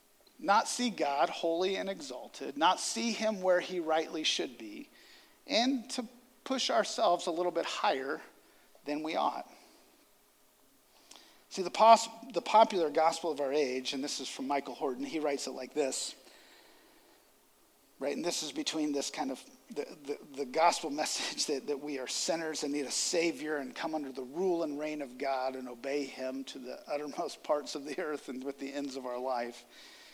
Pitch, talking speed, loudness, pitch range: 160 Hz, 185 wpm, -33 LUFS, 140-220 Hz